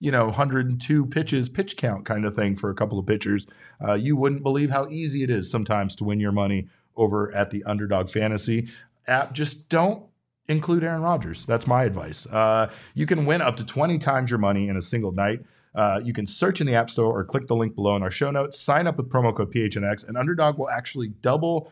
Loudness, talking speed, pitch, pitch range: -24 LUFS, 230 wpm, 120 Hz, 105-145 Hz